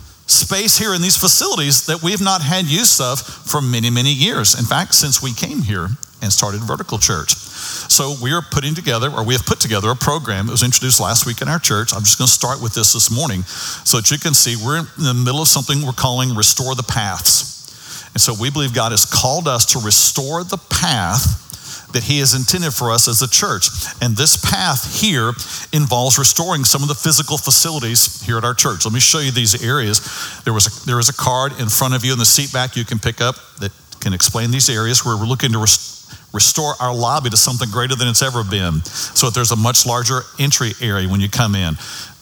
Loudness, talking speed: -14 LUFS, 235 wpm